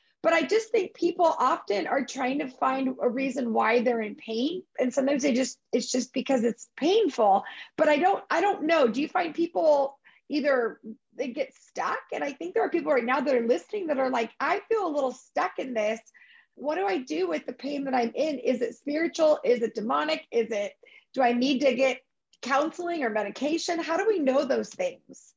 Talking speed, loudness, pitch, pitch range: 220 wpm, -27 LUFS, 275 Hz, 250-330 Hz